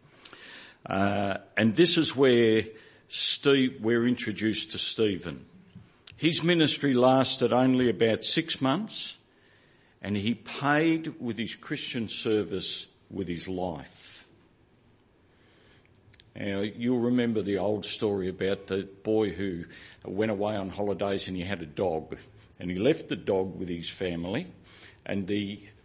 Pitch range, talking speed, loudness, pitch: 95-120 Hz, 130 wpm, -27 LUFS, 105 Hz